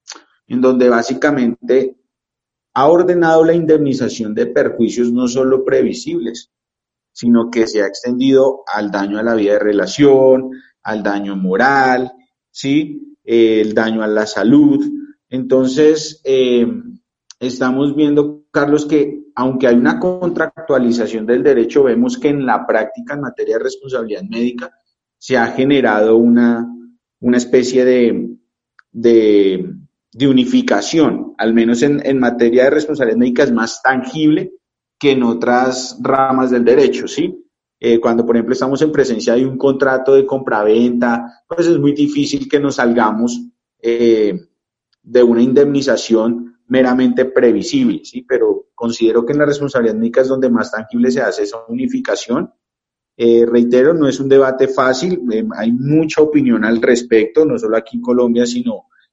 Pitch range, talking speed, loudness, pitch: 120-150 Hz, 145 wpm, -14 LUFS, 130 Hz